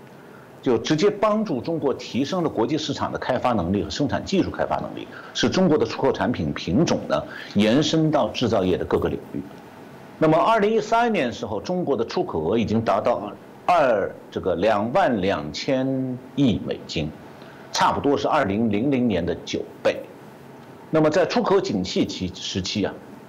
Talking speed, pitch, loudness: 265 characters per minute, 155 Hz, -22 LUFS